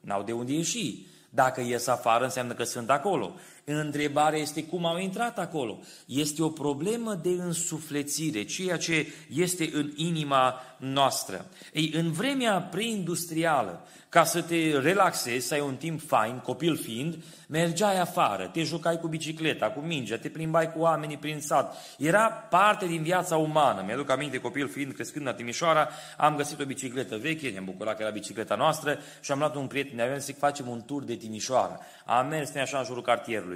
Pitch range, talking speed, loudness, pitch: 130-165 Hz, 180 wpm, -28 LUFS, 150 Hz